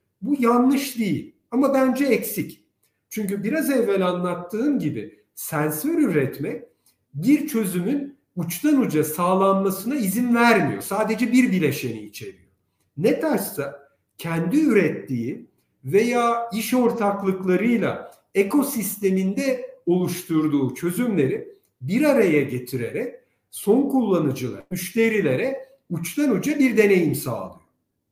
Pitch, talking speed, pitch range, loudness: 210 Hz, 95 wpm, 170-255 Hz, -22 LUFS